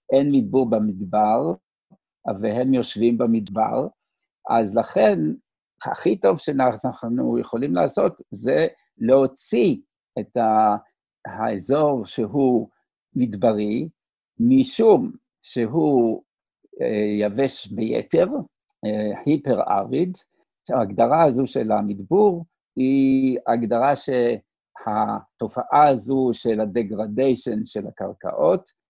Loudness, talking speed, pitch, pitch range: -21 LUFS, 75 wpm, 120 Hz, 110-135 Hz